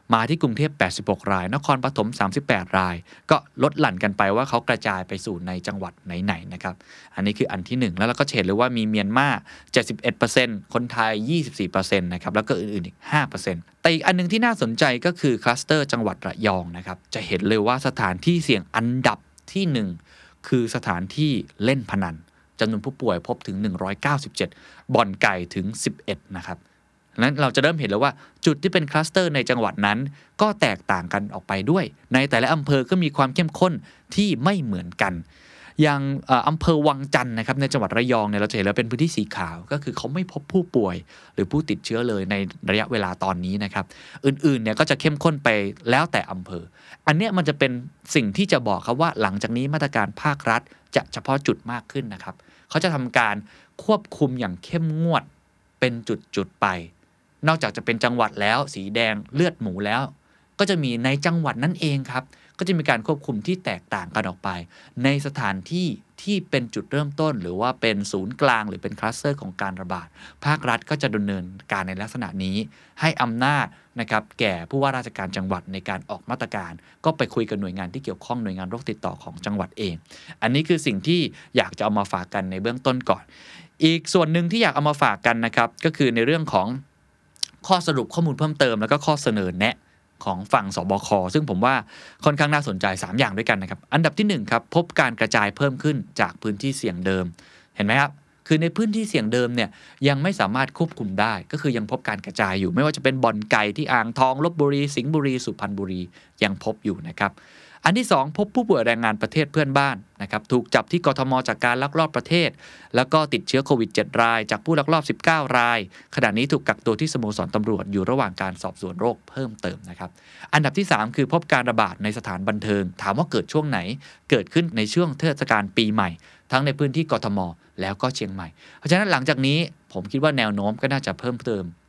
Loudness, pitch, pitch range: -23 LUFS, 120 Hz, 100-150 Hz